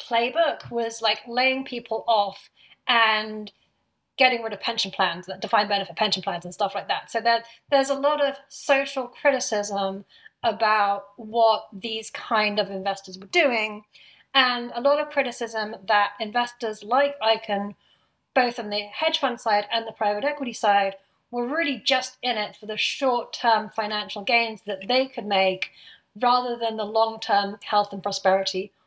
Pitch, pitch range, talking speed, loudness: 225 Hz, 205-245 Hz, 165 wpm, -24 LUFS